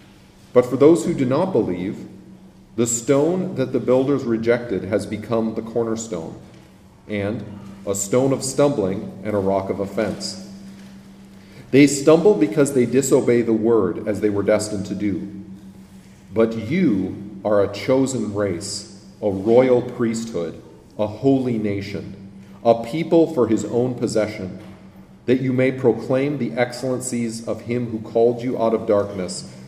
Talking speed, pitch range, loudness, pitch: 145 wpm, 100-130 Hz, -20 LUFS, 115 Hz